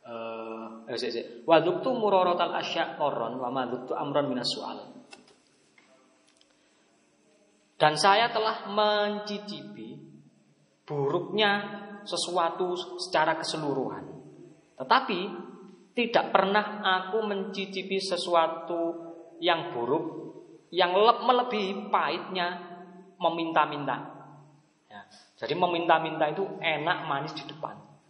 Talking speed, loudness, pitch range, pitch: 65 wpm, -28 LUFS, 165-205 Hz, 185 Hz